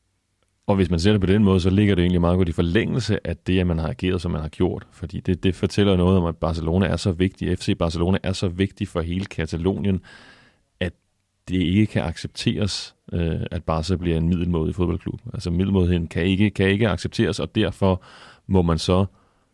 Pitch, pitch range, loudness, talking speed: 95 Hz, 85-100 Hz, -22 LUFS, 210 wpm